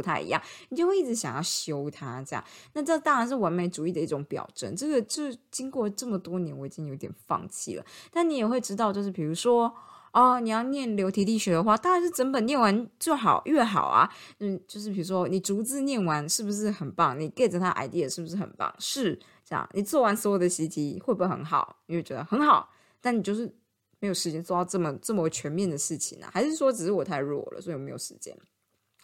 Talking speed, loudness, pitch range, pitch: 345 characters per minute, -28 LUFS, 170-245 Hz, 200 Hz